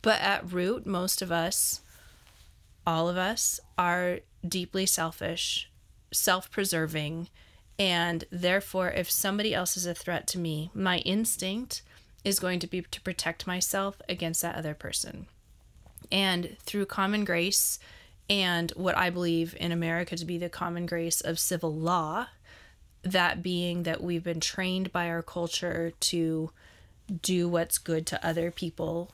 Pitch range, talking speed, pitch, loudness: 165-185 Hz, 145 wpm, 175 Hz, -29 LUFS